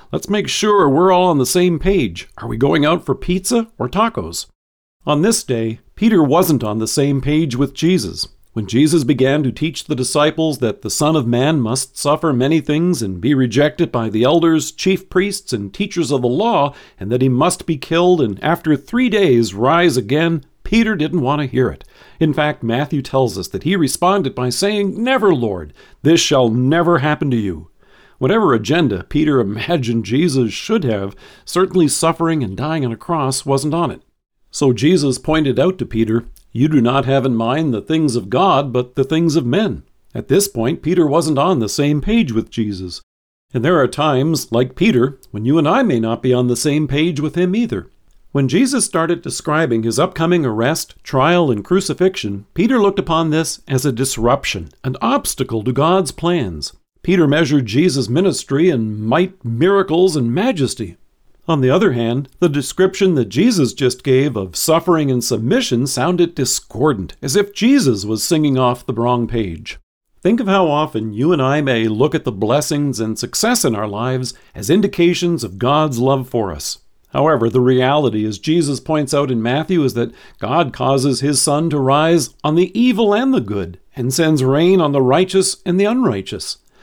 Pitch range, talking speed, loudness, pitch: 125-170 Hz, 190 wpm, -16 LUFS, 145 Hz